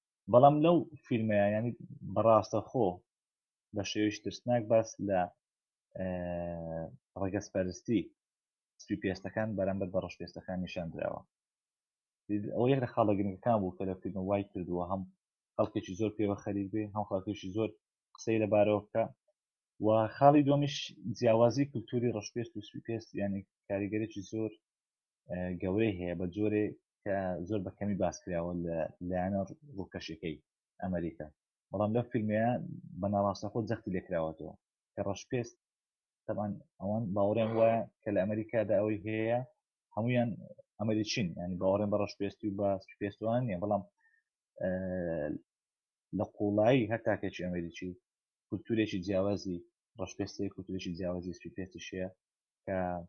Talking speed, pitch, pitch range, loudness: 115 wpm, 100 Hz, 95-110 Hz, -34 LUFS